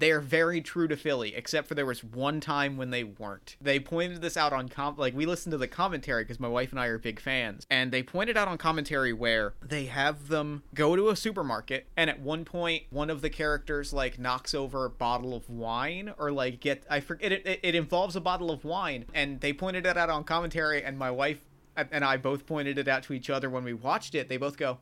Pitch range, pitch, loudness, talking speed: 130-160 Hz, 145 Hz, -30 LUFS, 250 wpm